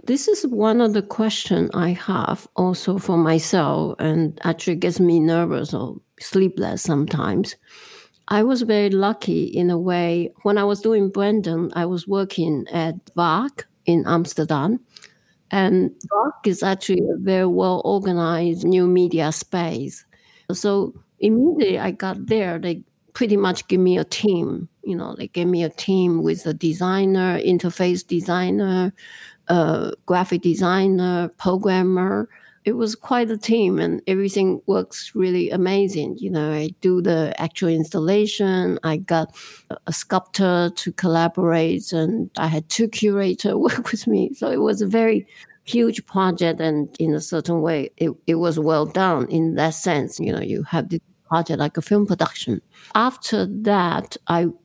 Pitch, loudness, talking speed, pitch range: 185 Hz, -21 LUFS, 155 wpm, 165-205 Hz